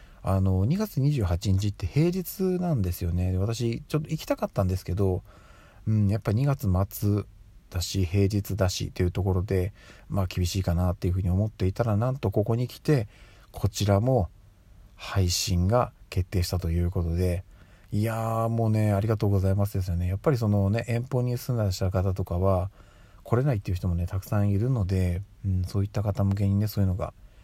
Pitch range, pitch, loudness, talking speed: 95-110 Hz, 100 Hz, -27 LUFS, 375 characters per minute